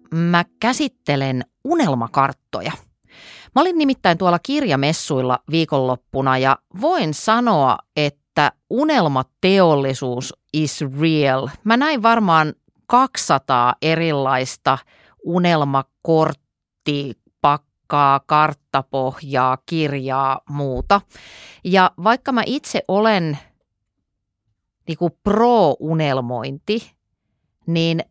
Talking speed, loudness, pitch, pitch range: 75 wpm, -18 LUFS, 150 Hz, 135-185 Hz